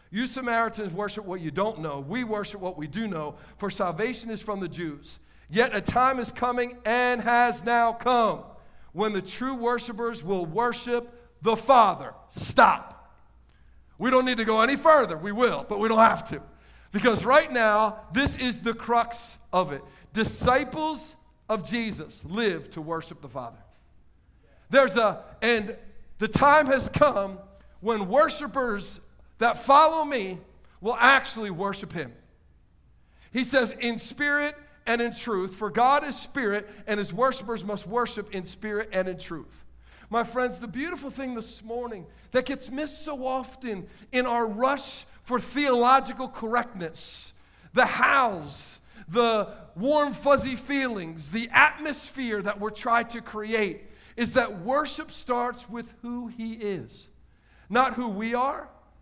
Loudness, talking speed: -25 LUFS, 150 wpm